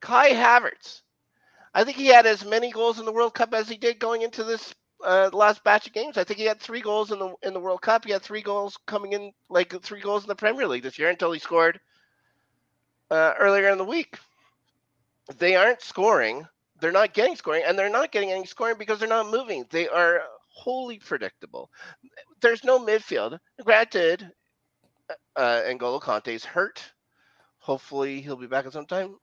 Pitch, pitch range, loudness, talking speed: 210 Hz, 180-230 Hz, -23 LUFS, 195 wpm